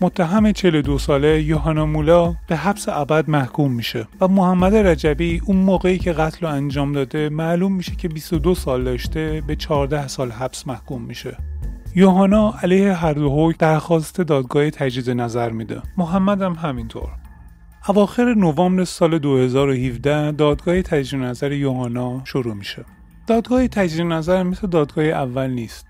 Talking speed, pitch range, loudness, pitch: 140 wpm, 135-180 Hz, -19 LUFS, 155 Hz